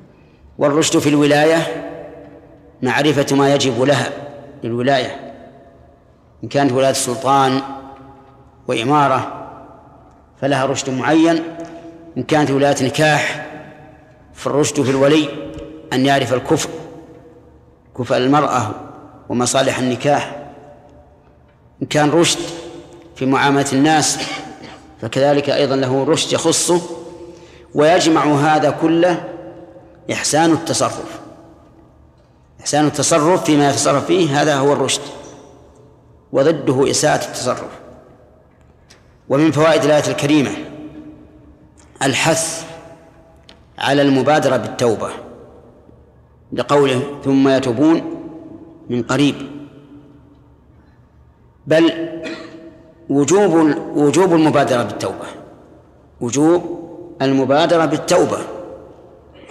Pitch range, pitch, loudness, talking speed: 135-160 Hz, 145 Hz, -16 LUFS, 80 wpm